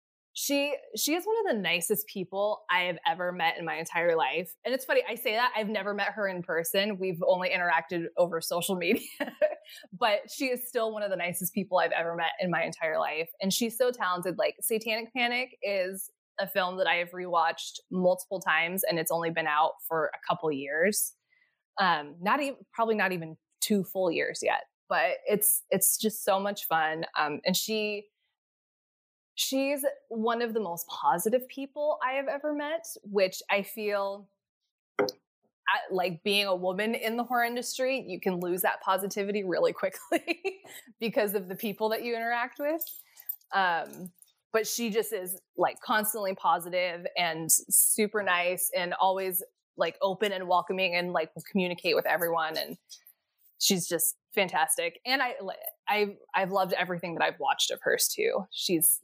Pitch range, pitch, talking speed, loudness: 180-240 Hz, 200 Hz, 175 wpm, -29 LUFS